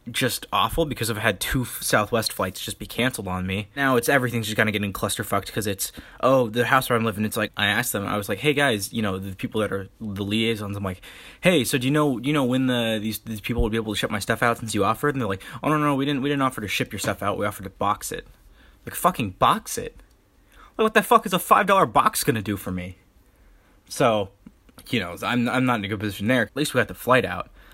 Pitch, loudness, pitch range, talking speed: 115 Hz, -23 LUFS, 105-130 Hz, 280 wpm